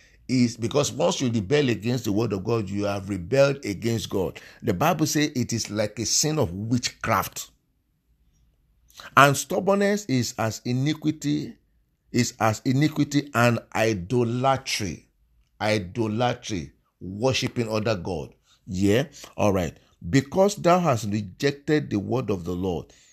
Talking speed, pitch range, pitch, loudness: 130 wpm, 105-140 Hz, 120 Hz, -24 LUFS